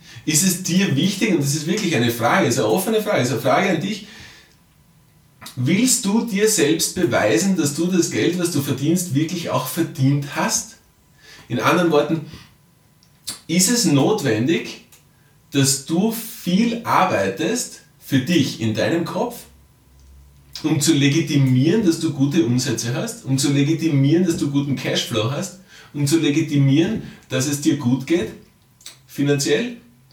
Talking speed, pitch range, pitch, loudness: 150 wpm, 140-175 Hz, 155 Hz, -19 LUFS